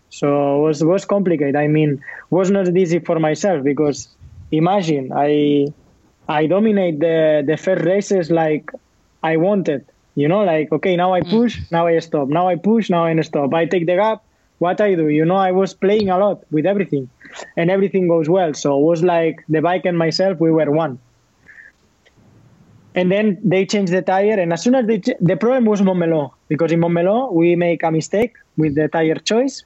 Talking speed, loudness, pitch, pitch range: 200 wpm, -17 LUFS, 170 Hz, 155-190 Hz